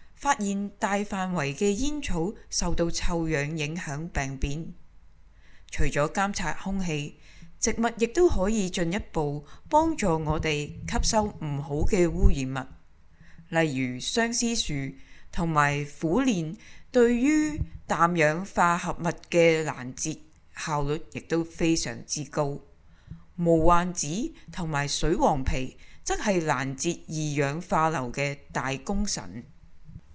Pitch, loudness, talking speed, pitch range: 165 Hz, -27 LUFS, 180 characters per minute, 145-195 Hz